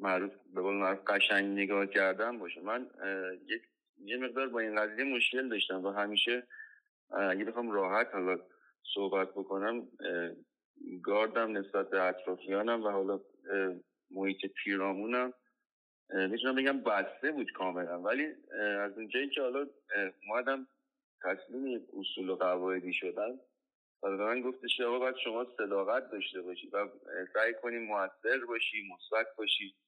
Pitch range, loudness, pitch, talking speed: 95-120 Hz, -34 LUFS, 100 Hz, 130 wpm